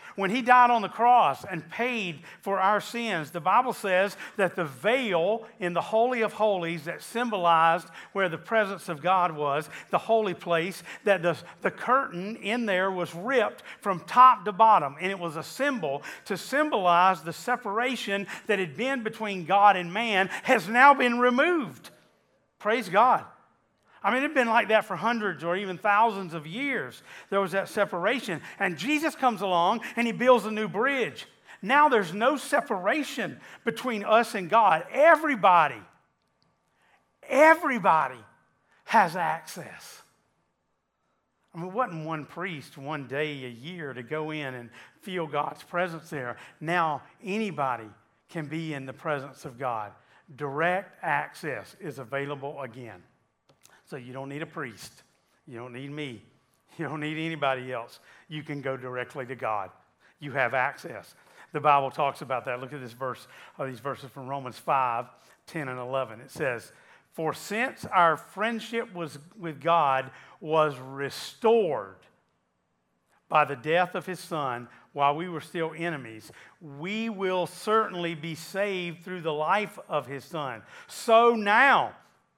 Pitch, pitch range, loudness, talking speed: 175 Hz, 150-220 Hz, -26 LUFS, 155 wpm